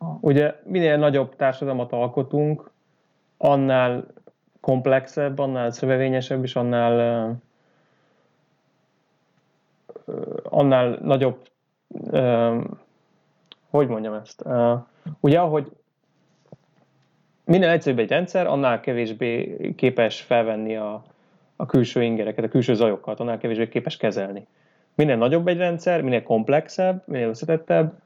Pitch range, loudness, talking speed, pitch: 120-155 Hz, -22 LUFS, 105 wpm, 130 Hz